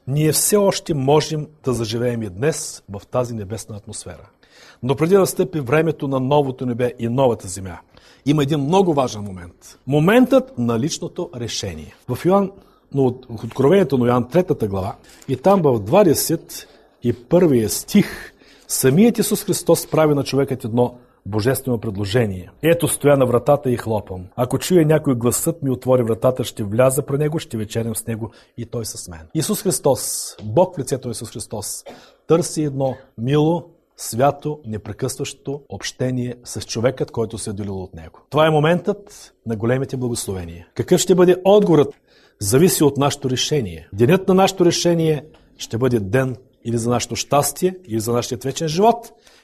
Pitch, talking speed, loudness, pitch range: 130 Hz, 160 wpm, -19 LUFS, 115-155 Hz